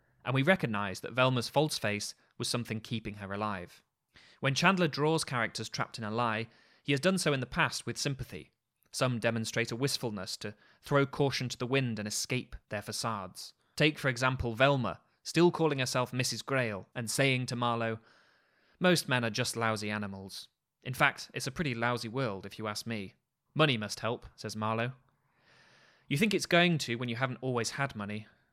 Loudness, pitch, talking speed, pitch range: -32 LUFS, 120 Hz, 185 wpm, 110-135 Hz